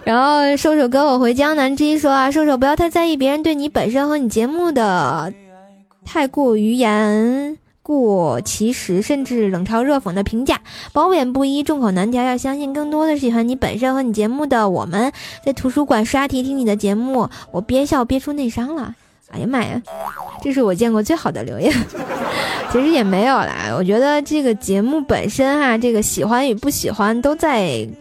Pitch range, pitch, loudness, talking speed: 215-285 Hz, 255 Hz, -17 LUFS, 285 characters per minute